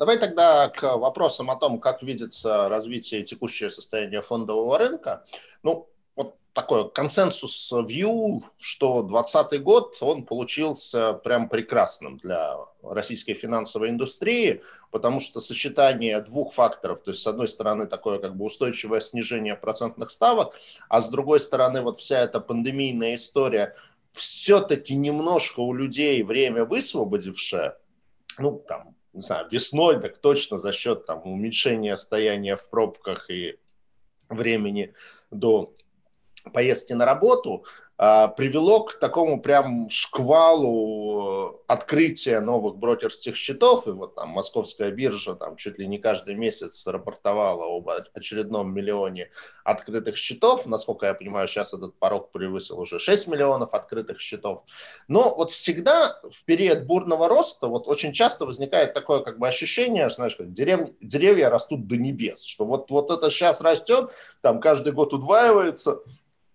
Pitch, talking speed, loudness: 140 Hz, 135 wpm, -23 LUFS